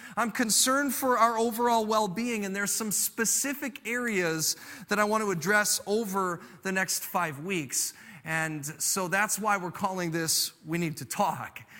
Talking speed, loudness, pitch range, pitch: 165 wpm, -28 LUFS, 175-230 Hz, 205 Hz